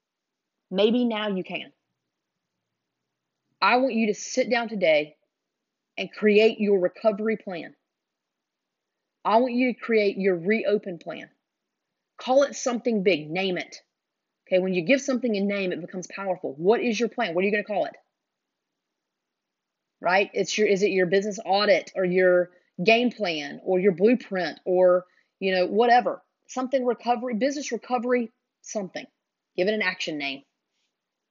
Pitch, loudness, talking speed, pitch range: 210 Hz, -24 LUFS, 155 wpm, 185-240 Hz